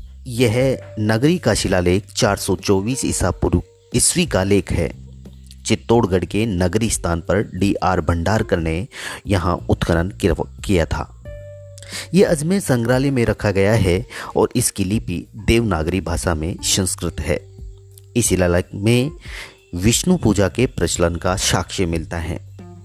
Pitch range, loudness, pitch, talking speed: 85-115 Hz, -19 LUFS, 95 Hz, 130 wpm